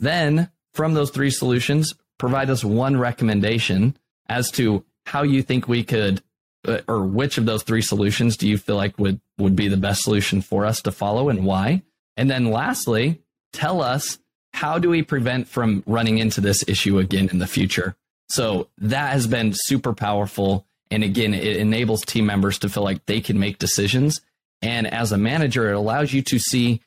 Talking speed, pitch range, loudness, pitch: 190 wpm, 100-130 Hz, -21 LUFS, 110 Hz